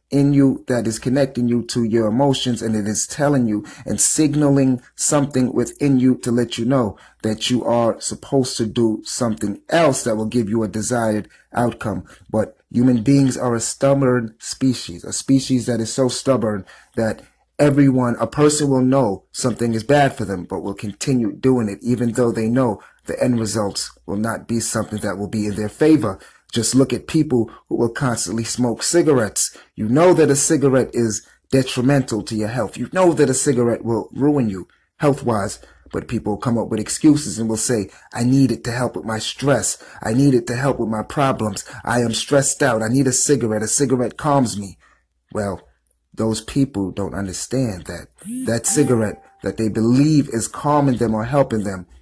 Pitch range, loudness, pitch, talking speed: 110-135 Hz, -19 LUFS, 120 Hz, 195 wpm